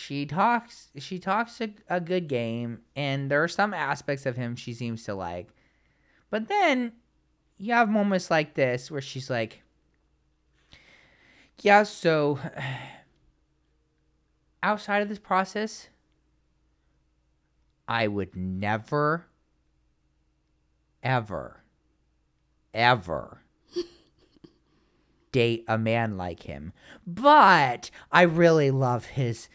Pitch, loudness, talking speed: 140 Hz, -25 LUFS, 100 wpm